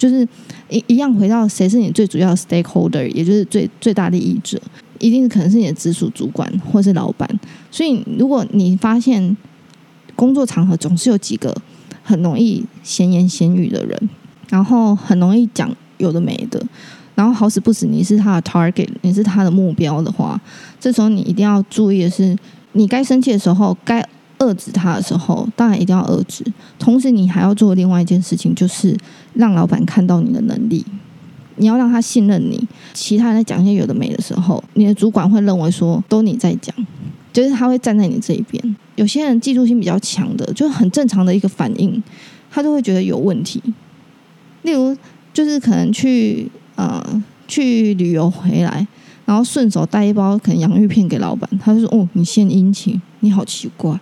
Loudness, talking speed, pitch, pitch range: -15 LUFS, 300 characters per minute, 210 Hz, 185-230 Hz